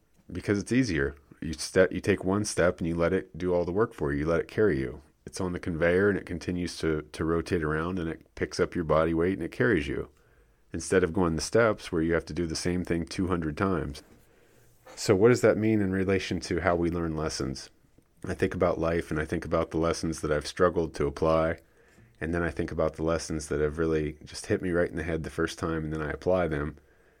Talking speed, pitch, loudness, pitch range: 250 wpm, 85 Hz, -28 LUFS, 80-90 Hz